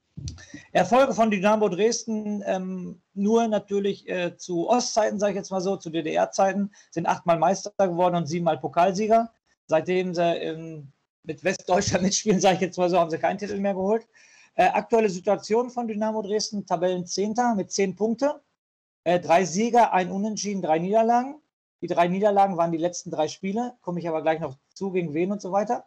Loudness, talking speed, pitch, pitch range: -24 LUFS, 180 wpm, 195 Hz, 175-215 Hz